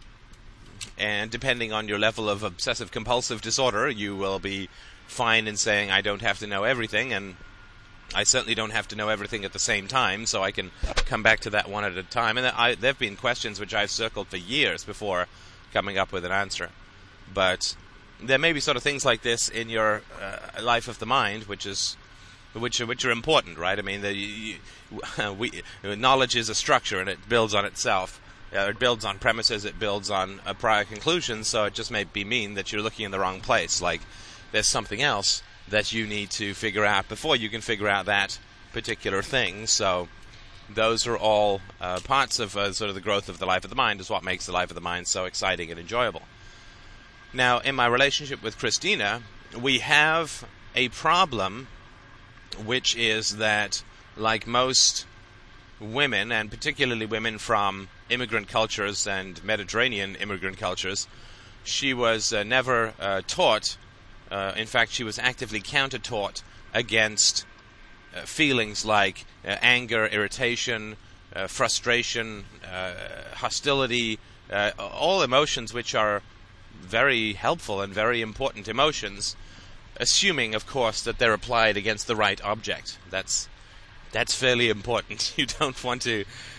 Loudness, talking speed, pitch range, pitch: -25 LUFS, 170 wpm, 100-115 Hz, 105 Hz